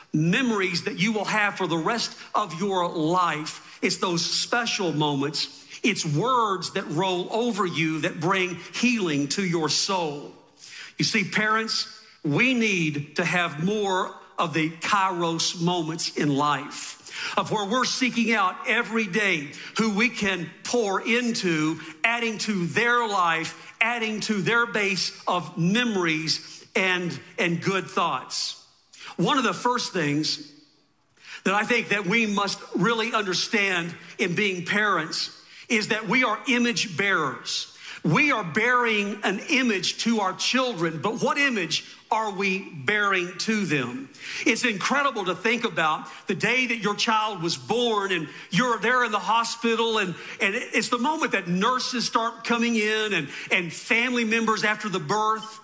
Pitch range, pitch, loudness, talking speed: 170-225 Hz, 200 Hz, -24 LUFS, 150 wpm